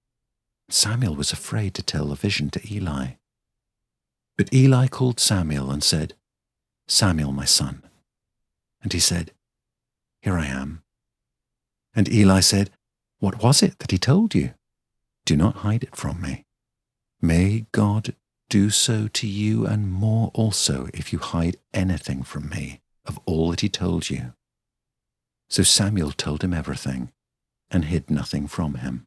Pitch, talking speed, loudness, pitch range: 95 Hz, 145 wpm, -22 LUFS, 75-110 Hz